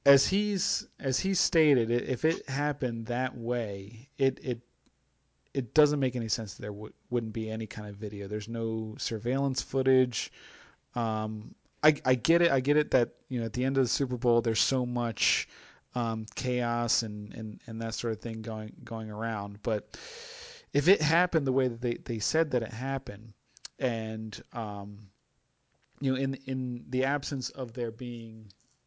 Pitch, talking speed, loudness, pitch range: 120 Hz, 180 wpm, -30 LUFS, 110-135 Hz